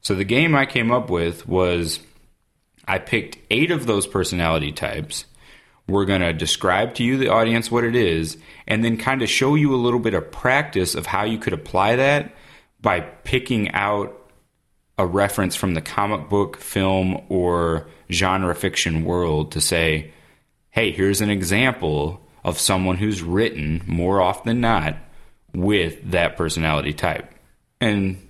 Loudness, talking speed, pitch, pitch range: -21 LUFS, 160 wpm, 95 Hz, 85-115 Hz